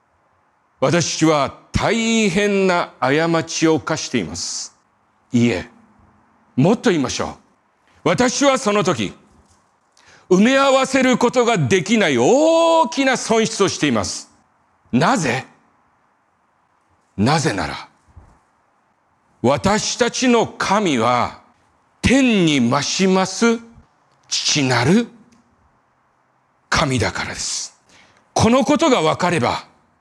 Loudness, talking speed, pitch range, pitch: -17 LUFS, 180 characters per minute, 165-245 Hz, 210 Hz